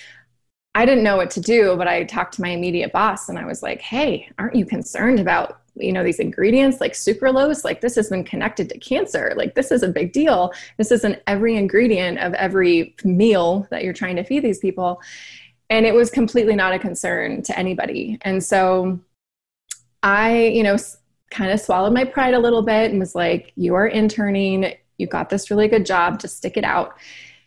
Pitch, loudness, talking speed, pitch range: 200 Hz, -19 LUFS, 205 wpm, 185-225 Hz